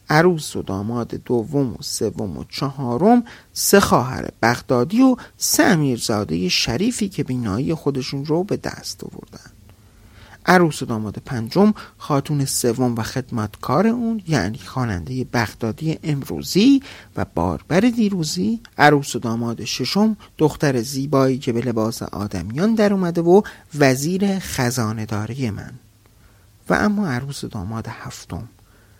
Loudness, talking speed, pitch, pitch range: -20 LUFS, 120 wpm, 130 Hz, 110-165 Hz